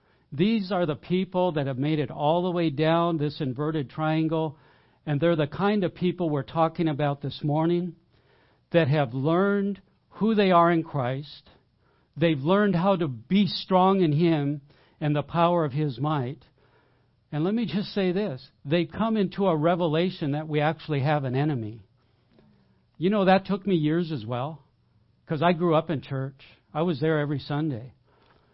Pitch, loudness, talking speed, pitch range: 155 Hz, -25 LUFS, 175 wpm, 140-175 Hz